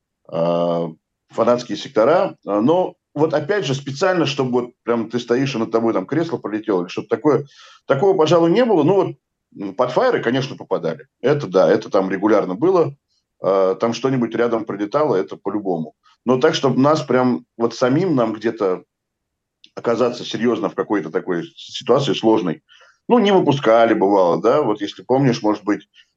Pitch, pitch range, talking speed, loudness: 120 Hz, 105-140 Hz, 155 wpm, -18 LUFS